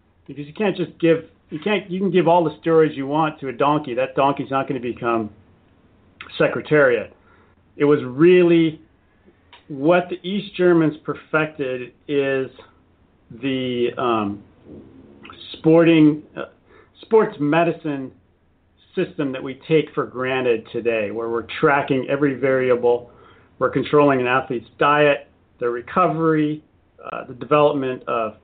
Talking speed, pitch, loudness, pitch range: 135 wpm, 140 Hz, -20 LUFS, 120-160 Hz